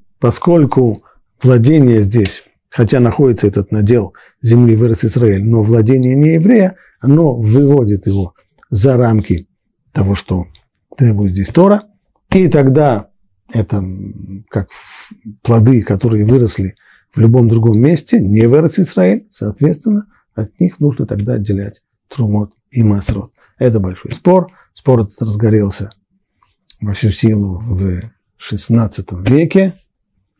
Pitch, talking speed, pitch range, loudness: 115 Hz, 115 wpm, 100-135 Hz, -12 LUFS